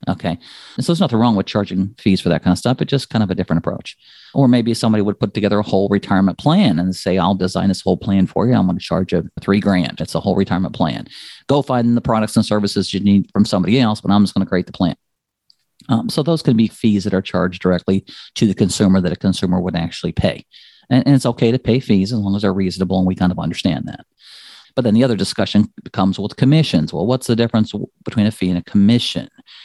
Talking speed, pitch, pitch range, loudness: 255 wpm, 100 Hz, 95-115 Hz, -17 LUFS